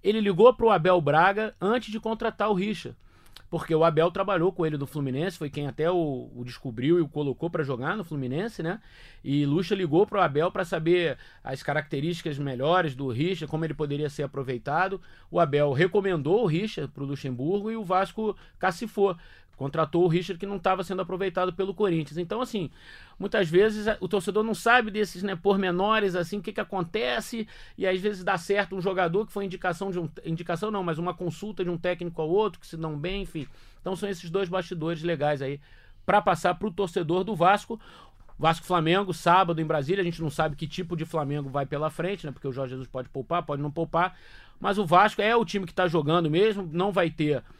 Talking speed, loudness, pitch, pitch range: 210 wpm, -27 LUFS, 180 Hz, 155-200 Hz